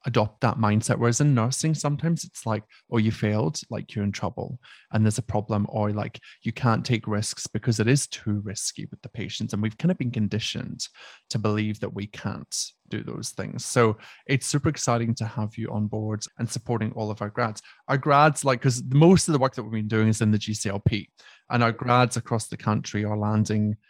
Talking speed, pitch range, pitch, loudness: 220 wpm, 105-130 Hz, 115 Hz, -25 LUFS